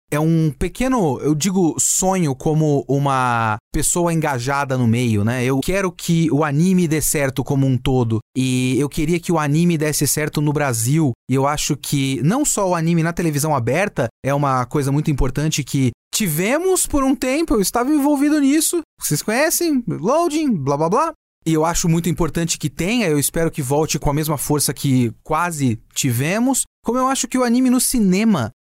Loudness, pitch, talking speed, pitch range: -18 LUFS, 155 Hz, 190 wpm, 140-195 Hz